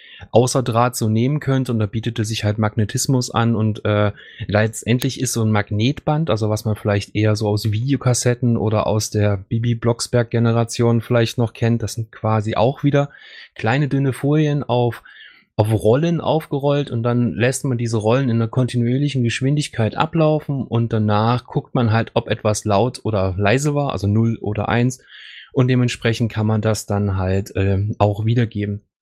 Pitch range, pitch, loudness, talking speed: 110-125 Hz, 115 Hz, -19 LUFS, 170 wpm